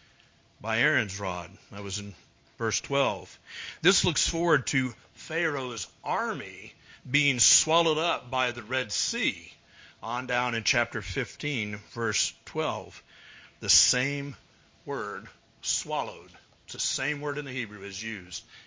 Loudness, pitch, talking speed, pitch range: -27 LUFS, 125 Hz, 130 wpm, 110-140 Hz